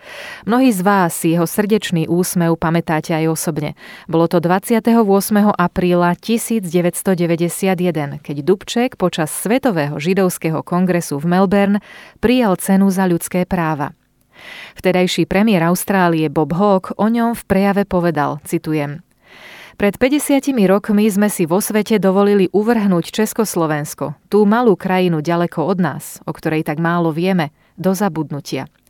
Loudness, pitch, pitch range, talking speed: -16 LUFS, 185 Hz, 165-205 Hz, 130 wpm